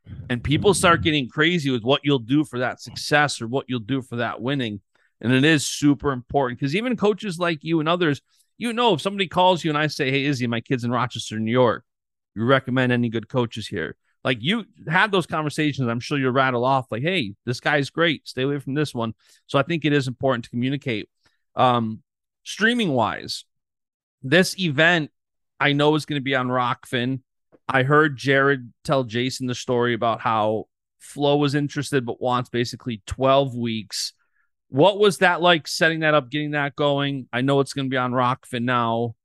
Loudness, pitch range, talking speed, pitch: -22 LUFS, 125-150 Hz, 200 wpm, 135 Hz